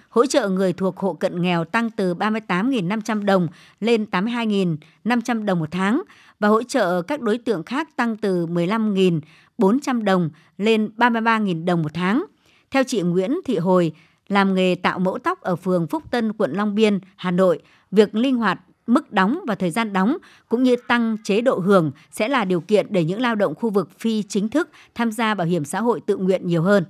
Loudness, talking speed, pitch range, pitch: -21 LUFS, 200 wpm, 180-235 Hz, 205 Hz